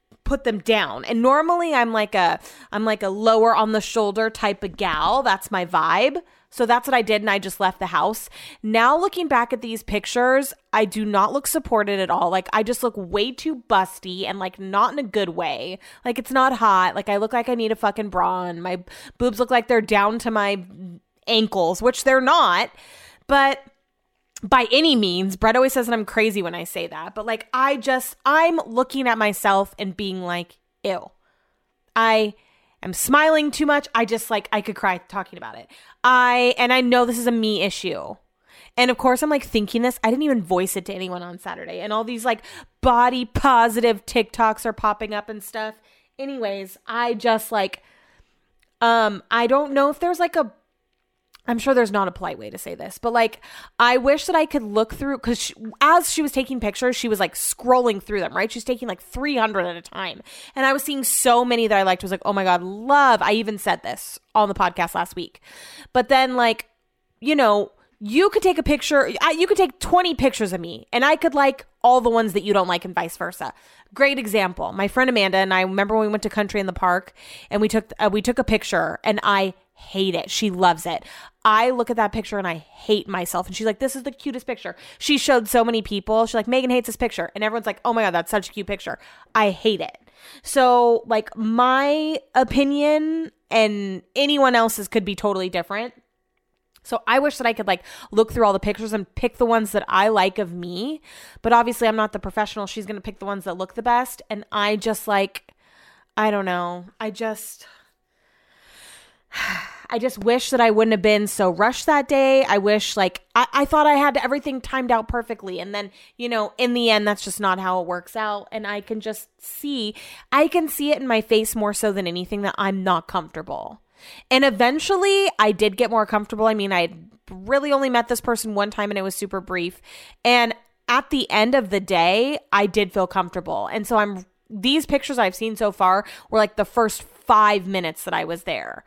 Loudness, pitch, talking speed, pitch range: -20 LUFS, 220 Hz, 220 wpm, 200-255 Hz